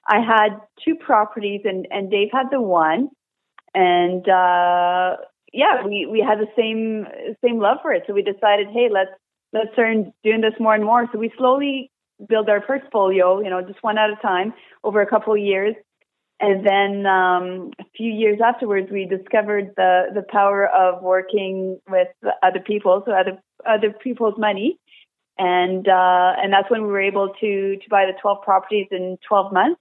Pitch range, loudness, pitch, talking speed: 190-220 Hz, -19 LUFS, 205 Hz, 185 wpm